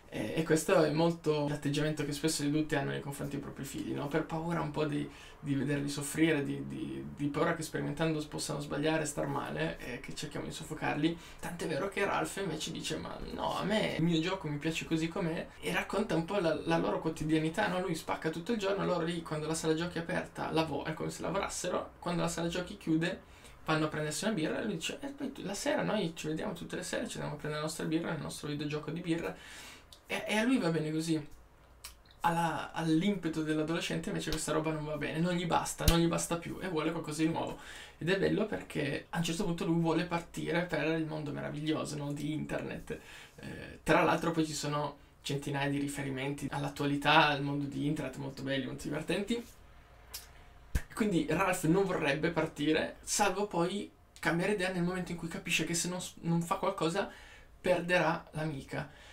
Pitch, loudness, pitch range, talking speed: 160 Hz, -34 LUFS, 150-170 Hz, 205 wpm